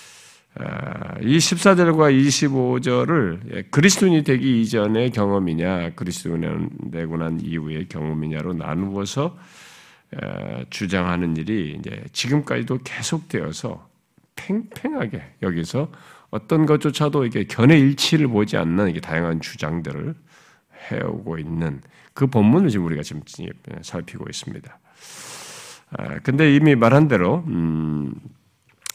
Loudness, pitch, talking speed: -20 LUFS, 115 Hz, 260 characters per minute